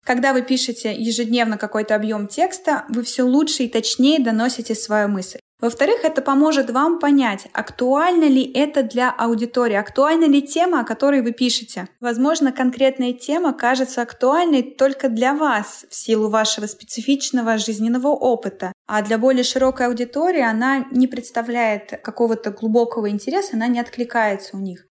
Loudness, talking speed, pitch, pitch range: -19 LUFS, 150 wpm, 245 Hz, 225-275 Hz